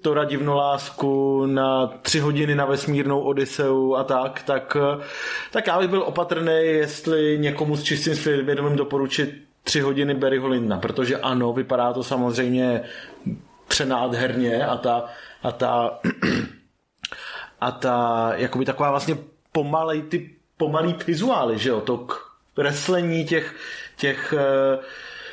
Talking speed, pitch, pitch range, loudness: 125 wpm, 140 Hz, 130-155 Hz, -23 LUFS